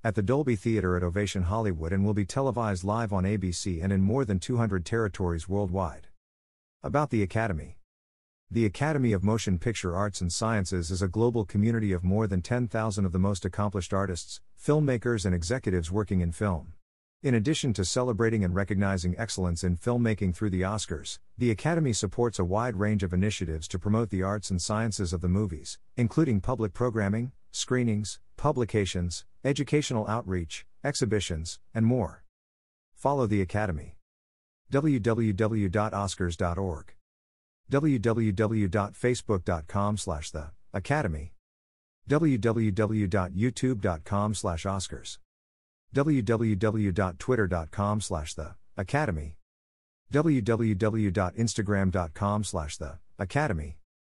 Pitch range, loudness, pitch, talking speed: 90-115 Hz, -28 LUFS, 100 Hz, 120 wpm